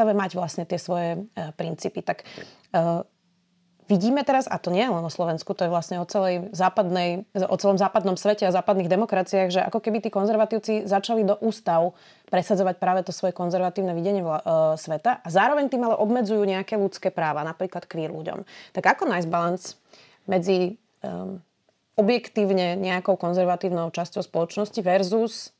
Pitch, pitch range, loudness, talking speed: 185 Hz, 175-205 Hz, -24 LUFS, 165 wpm